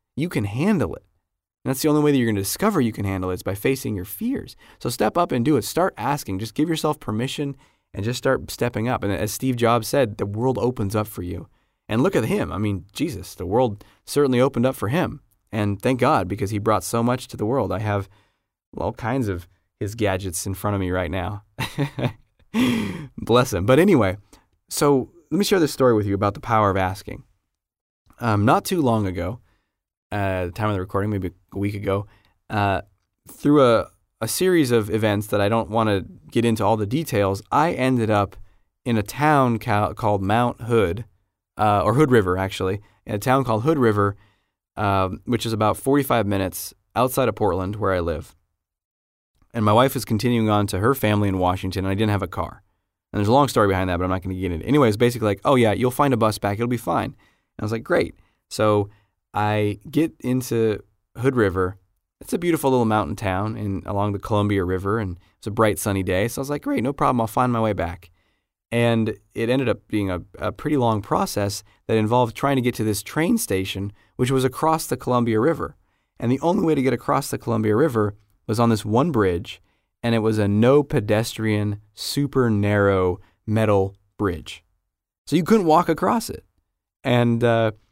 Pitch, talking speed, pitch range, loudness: 105 Hz, 215 wpm, 100-125 Hz, -22 LUFS